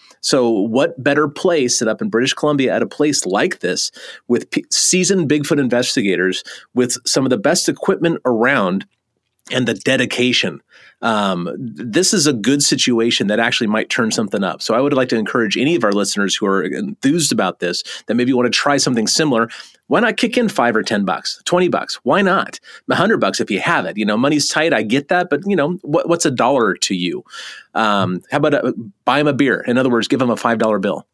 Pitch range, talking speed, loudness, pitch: 120-175 Hz, 220 wpm, -16 LUFS, 145 Hz